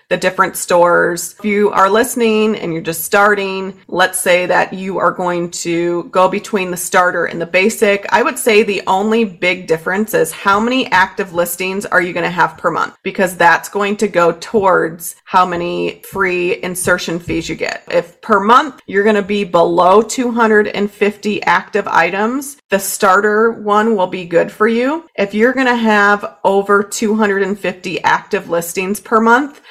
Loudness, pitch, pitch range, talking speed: -14 LUFS, 195 Hz, 180-215 Hz, 175 wpm